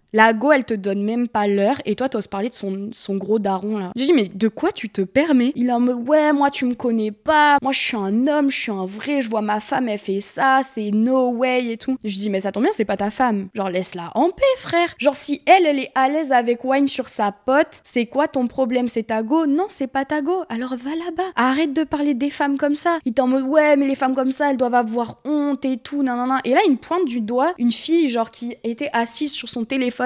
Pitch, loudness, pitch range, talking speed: 255 Hz, -19 LUFS, 225-290 Hz, 280 wpm